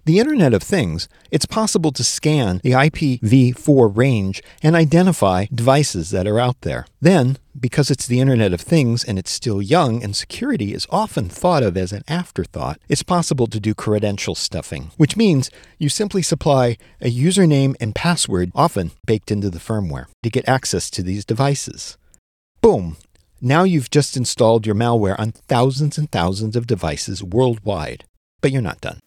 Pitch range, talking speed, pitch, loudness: 105-150 Hz, 170 wpm, 125 Hz, -18 LUFS